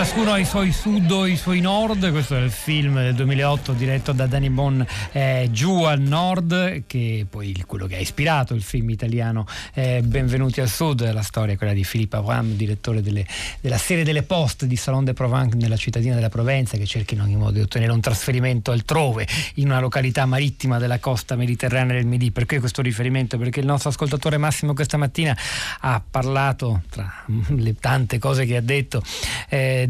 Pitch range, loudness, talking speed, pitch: 115-140 Hz, -21 LUFS, 195 wpm, 130 Hz